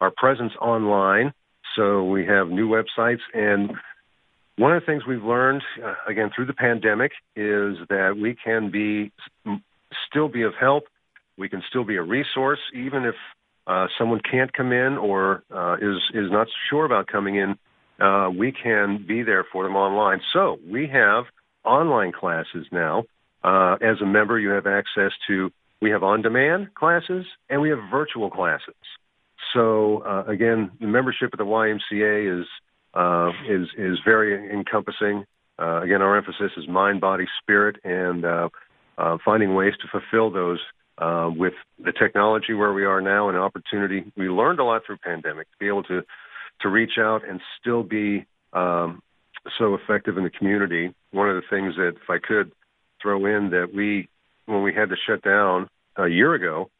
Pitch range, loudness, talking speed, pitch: 95-110 Hz, -22 LUFS, 175 wpm, 105 Hz